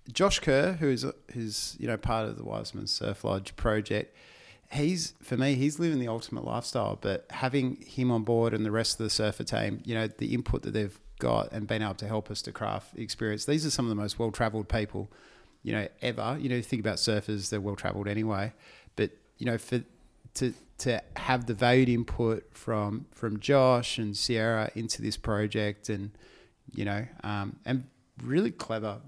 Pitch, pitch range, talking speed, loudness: 110 Hz, 105-125 Hz, 195 wpm, -30 LUFS